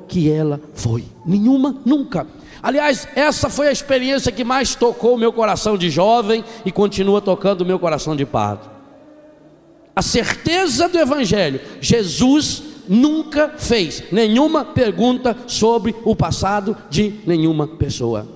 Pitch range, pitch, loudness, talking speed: 175-275 Hz, 225 Hz, -17 LUFS, 135 wpm